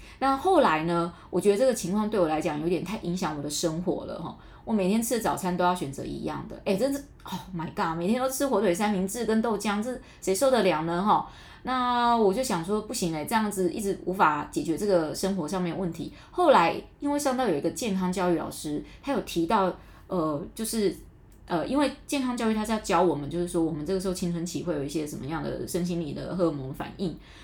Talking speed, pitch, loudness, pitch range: 350 characters per minute, 185 Hz, -27 LUFS, 170-220 Hz